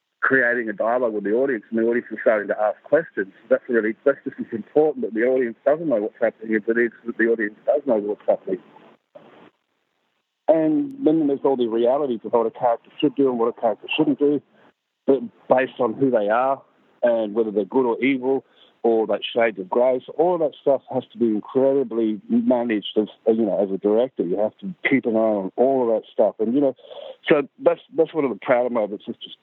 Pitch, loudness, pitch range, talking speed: 120 Hz, -22 LUFS, 115-140 Hz, 225 wpm